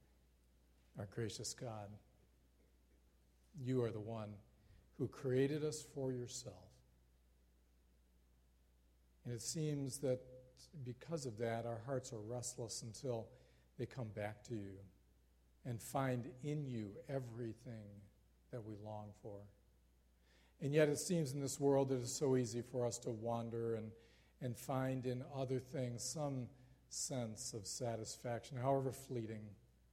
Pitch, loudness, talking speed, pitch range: 115 Hz, -43 LUFS, 130 wpm, 90-130 Hz